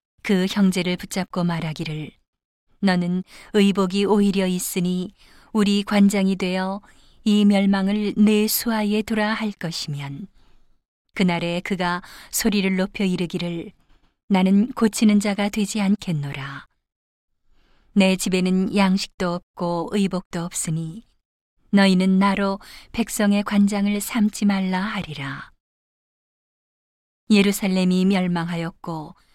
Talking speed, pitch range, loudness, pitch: 230 characters per minute, 175-205 Hz, -21 LUFS, 195 Hz